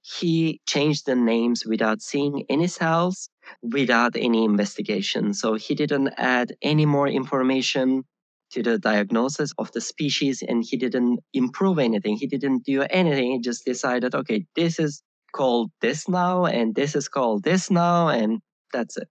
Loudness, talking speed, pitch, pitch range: -23 LUFS, 160 wpm, 135 Hz, 120-155 Hz